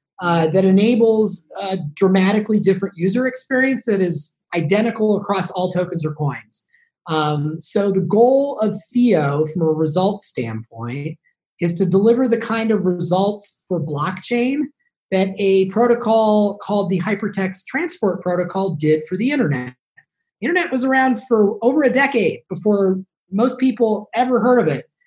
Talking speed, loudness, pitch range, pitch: 145 wpm, -18 LUFS, 180-235 Hz, 200 Hz